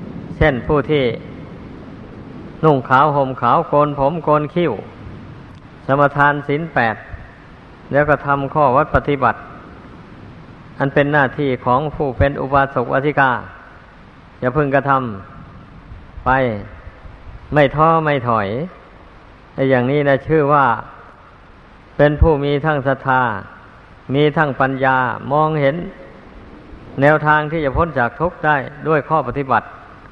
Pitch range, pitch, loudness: 125-150 Hz, 140 Hz, -16 LUFS